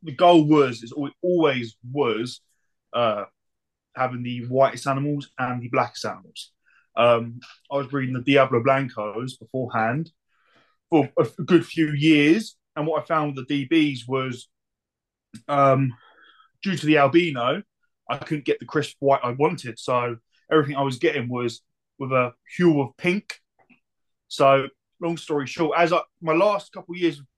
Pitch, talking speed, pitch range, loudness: 140 Hz, 160 wpm, 125-160 Hz, -23 LUFS